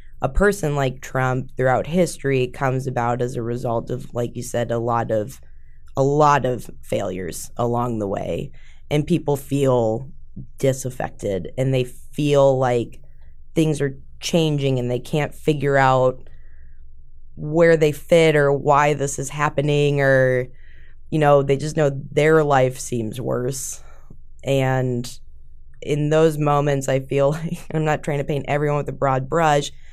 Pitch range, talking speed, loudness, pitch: 120-145 Hz, 150 wpm, -20 LUFS, 135 Hz